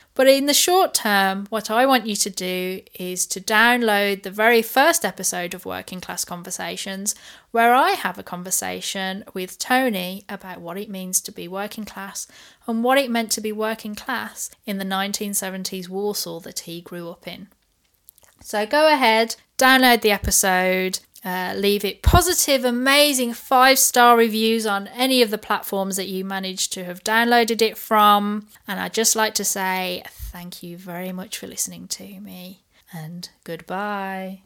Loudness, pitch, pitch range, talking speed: -19 LUFS, 200 Hz, 185-230 Hz, 170 wpm